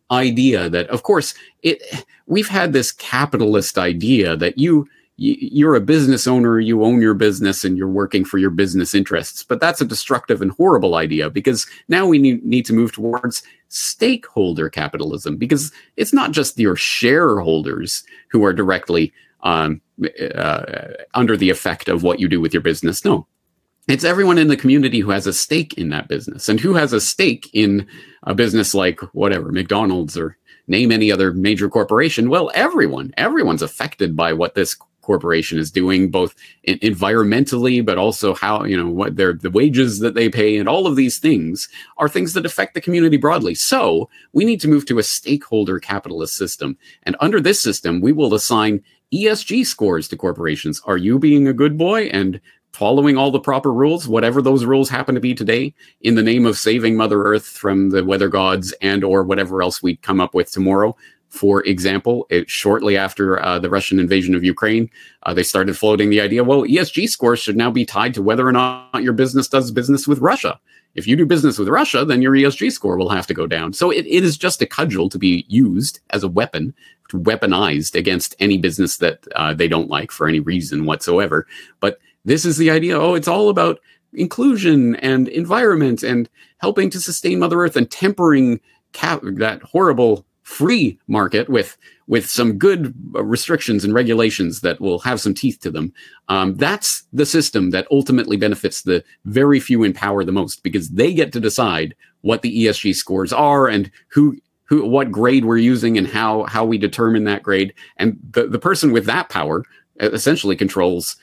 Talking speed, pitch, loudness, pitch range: 190 wpm, 115 Hz, -17 LUFS, 100-140 Hz